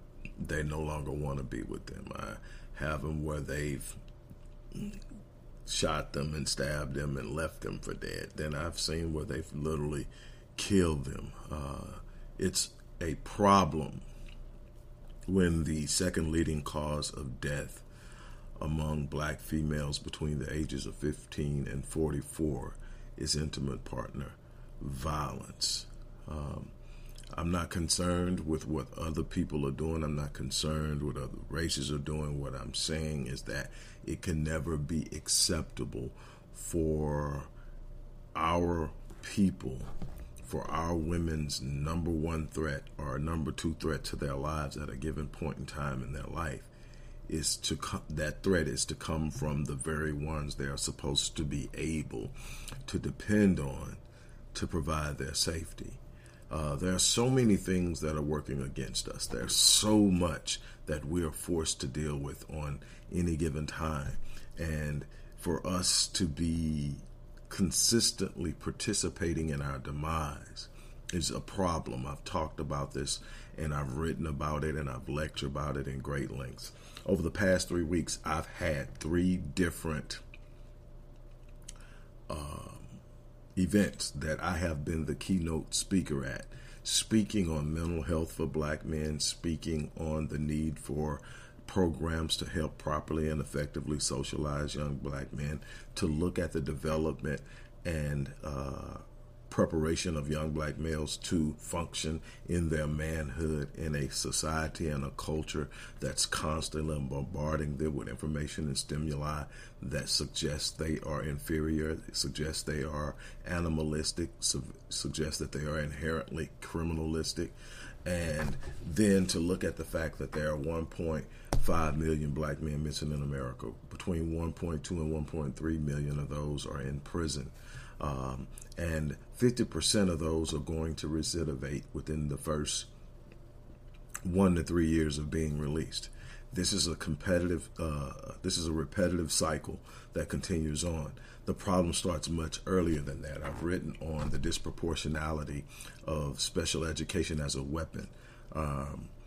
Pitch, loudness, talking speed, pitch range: 75 Hz, -34 LUFS, 145 wpm, 70-85 Hz